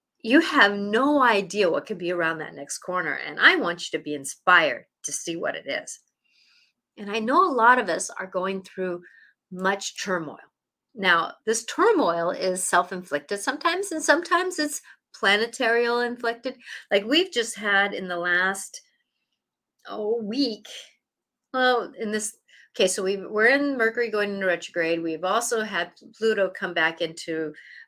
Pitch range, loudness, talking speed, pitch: 180-250 Hz, -23 LUFS, 160 wpm, 210 Hz